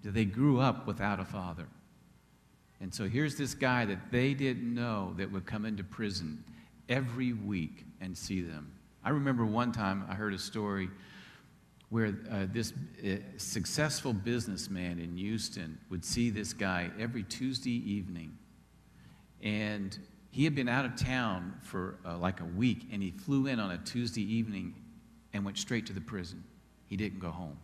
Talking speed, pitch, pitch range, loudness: 170 wpm, 105 Hz, 95-120 Hz, -35 LUFS